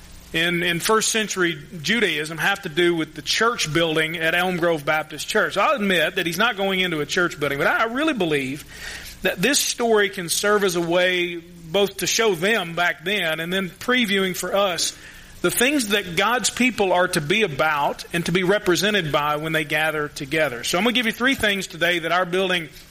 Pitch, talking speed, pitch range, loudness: 180 Hz, 210 wpm, 165-205 Hz, -21 LUFS